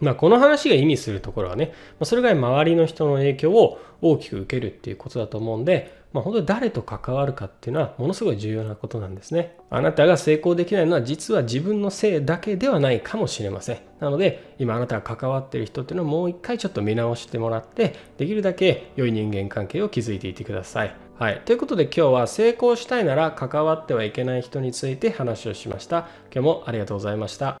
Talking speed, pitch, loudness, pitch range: 485 characters per minute, 135 Hz, -22 LUFS, 115-170 Hz